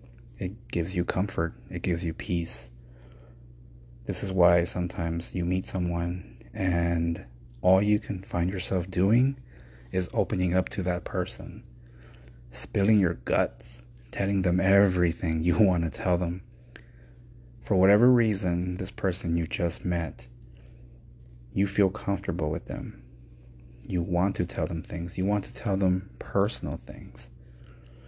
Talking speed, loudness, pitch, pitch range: 140 wpm, -27 LUFS, 85 Hz, 60-95 Hz